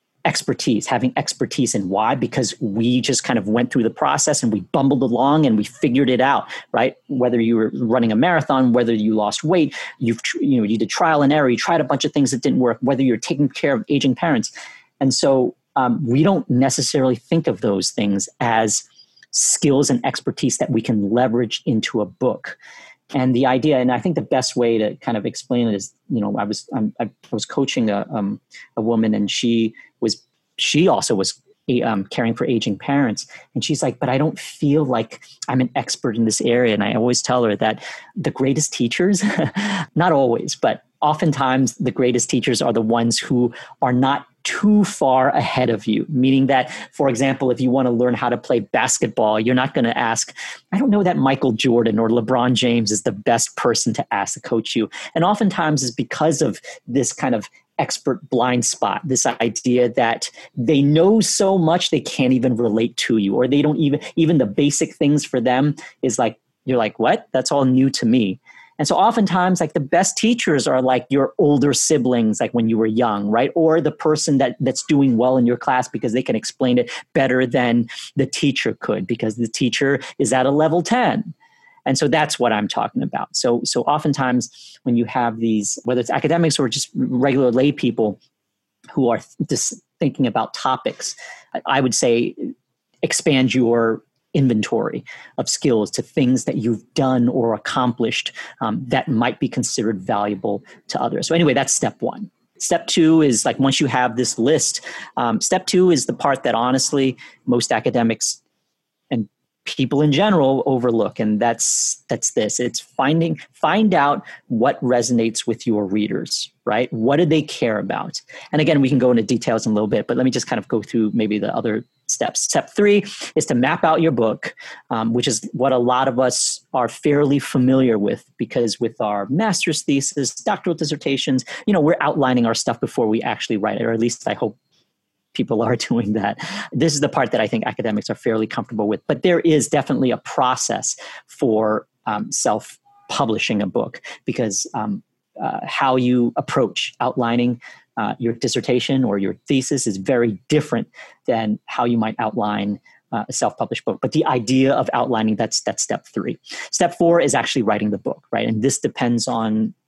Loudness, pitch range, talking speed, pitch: -19 LUFS, 115-145 Hz, 195 wpm, 130 Hz